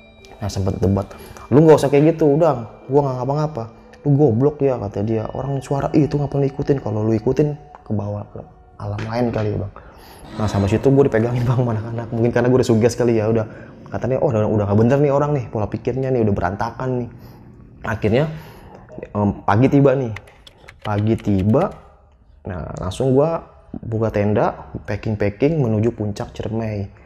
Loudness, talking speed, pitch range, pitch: -19 LUFS, 175 wpm, 105-135 Hz, 115 Hz